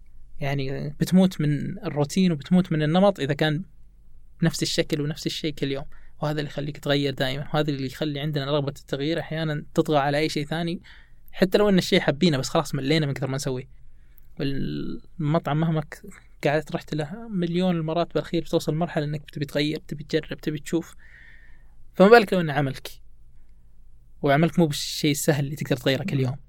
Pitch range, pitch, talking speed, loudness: 140-165 Hz, 150 Hz, 170 wpm, -24 LUFS